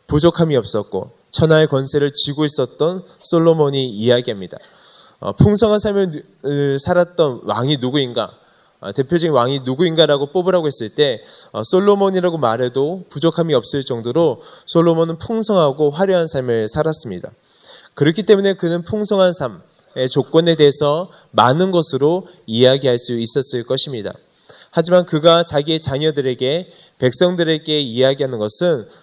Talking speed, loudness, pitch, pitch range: 325 characters per minute, -16 LUFS, 155 Hz, 135-175 Hz